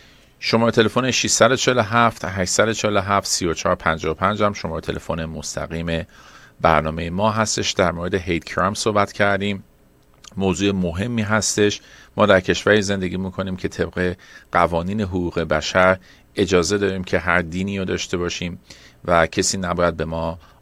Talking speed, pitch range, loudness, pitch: 130 wpm, 85-105 Hz, -20 LUFS, 95 Hz